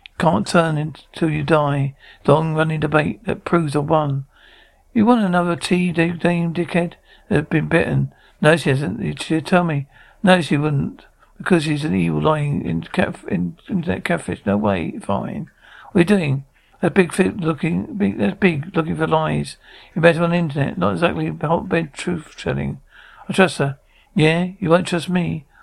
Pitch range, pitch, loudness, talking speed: 145-175 Hz, 160 Hz, -19 LUFS, 175 wpm